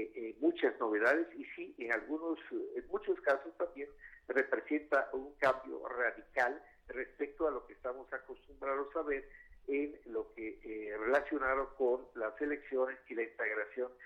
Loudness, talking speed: -37 LUFS, 140 wpm